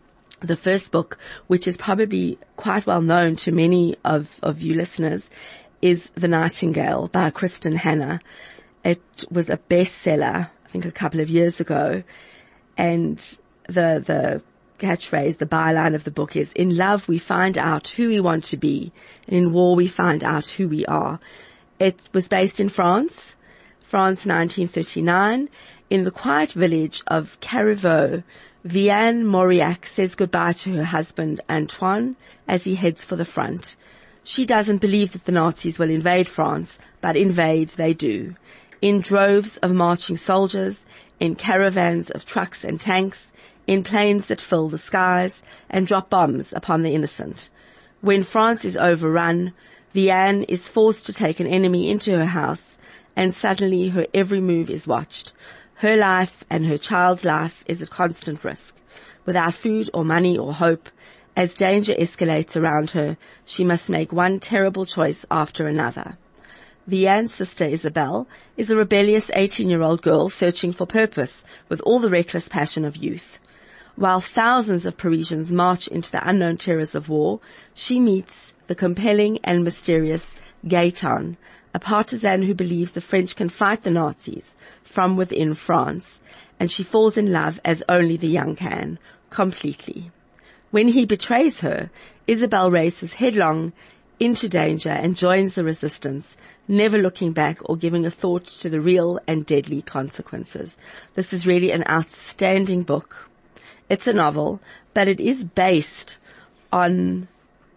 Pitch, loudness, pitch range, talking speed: 180 Hz, -21 LUFS, 165-195 Hz, 155 wpm